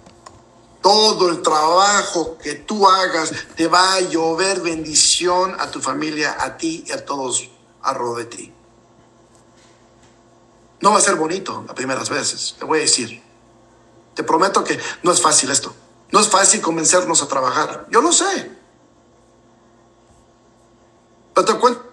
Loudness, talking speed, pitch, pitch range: -16 LUFS, 150 wpm, 135 Hz, 115-180 Hz